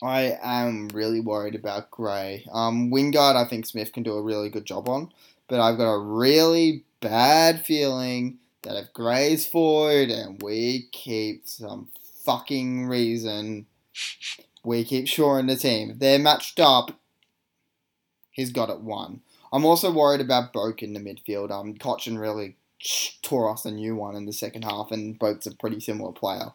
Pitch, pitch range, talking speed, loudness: 115 Hz, 105-130 Hz, 165 wpm, -24 LUFS